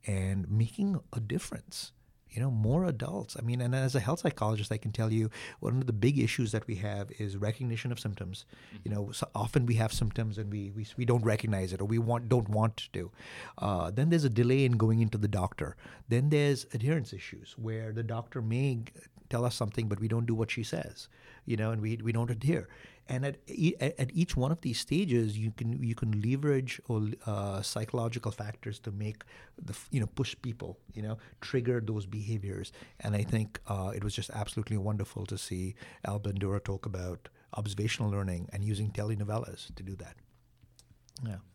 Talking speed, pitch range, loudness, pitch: 200 wpm, 105-125 Hz, -33 LUFS, 115 Hz